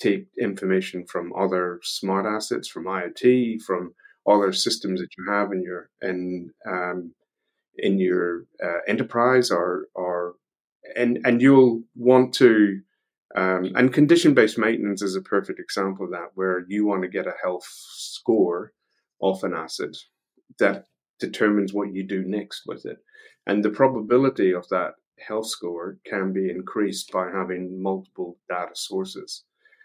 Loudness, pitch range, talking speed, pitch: -23 LUFS, 90-120 Hz, 150 wpm, 95 Hz